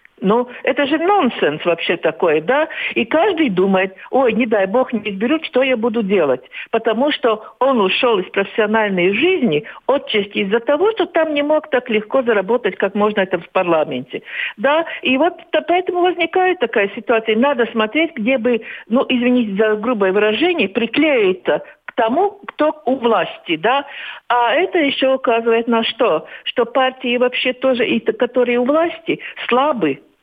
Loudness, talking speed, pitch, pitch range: -17 LUFS, 160 wpm, 250 Hz, 220-305 Hz